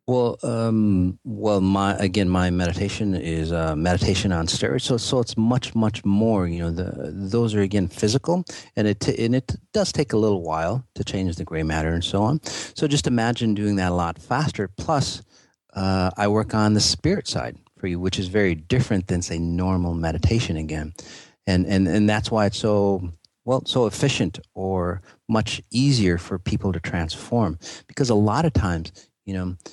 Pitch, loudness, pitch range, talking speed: 100 Hz, -23 LUFS, 90-110 Hz, 190 wpm